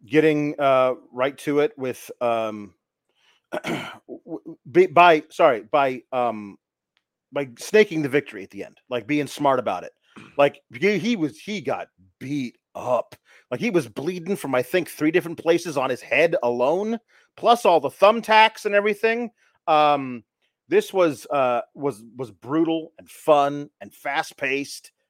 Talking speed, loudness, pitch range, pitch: 150 wpm, -22 LUFS, 130-180 Hz, 150 Hz